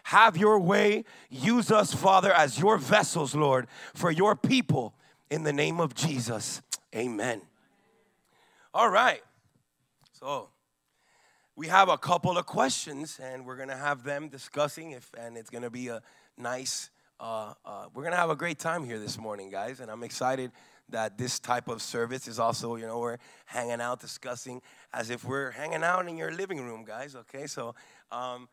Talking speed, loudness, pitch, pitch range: 180 wpm, -28 LUFS, 135 Hz, 120-165 Hz